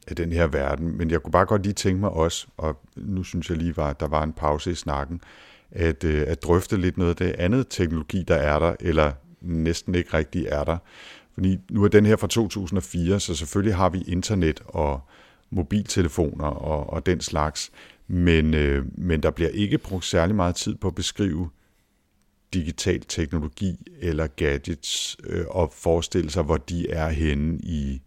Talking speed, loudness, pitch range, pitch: 185 wpm, -24 LUFS, 80-95 Hz, 85 Hz